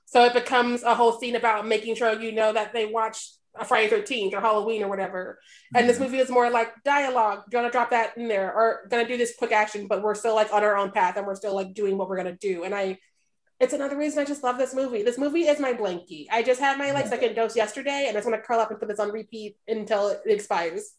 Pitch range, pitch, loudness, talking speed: 210-255 Hz, 230 Hz, -24 LUFS, 270 wpm